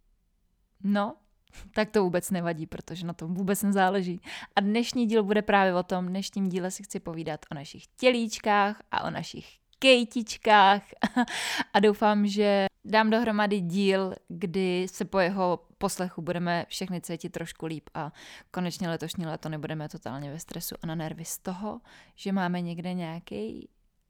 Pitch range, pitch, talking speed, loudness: 170-210 Hz, 190 Hz, 155 wpm, -28 LUFS